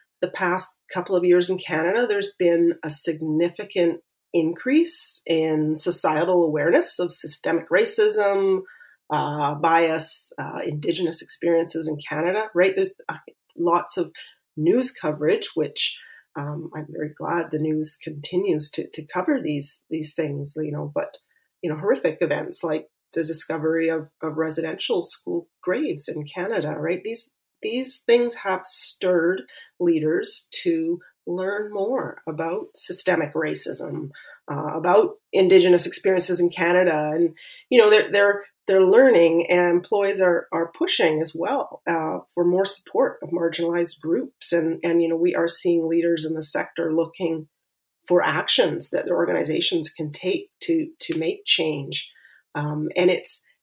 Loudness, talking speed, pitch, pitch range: -22 LUFS, 145 wpm, 170 Hz, 160-190 Hz